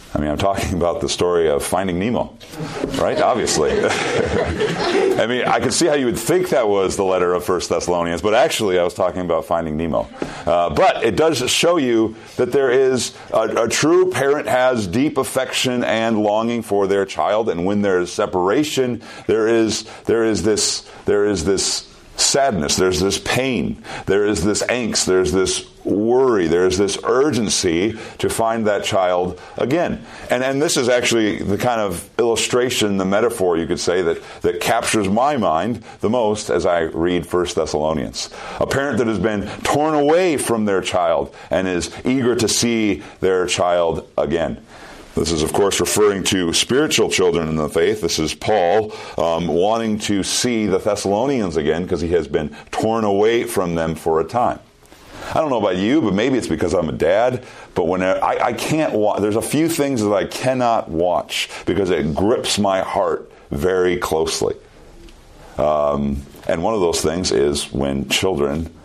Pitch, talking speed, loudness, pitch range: 105 Hz, 180 wpm, -18 LUFS, 90-125 Hz